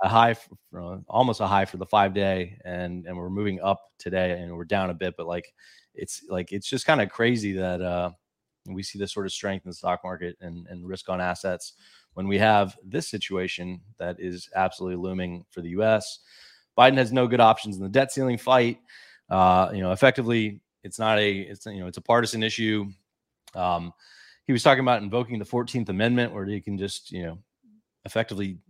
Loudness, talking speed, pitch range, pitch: -25 LUFS, 215 wpm, 90-110 Hz, 100 Hz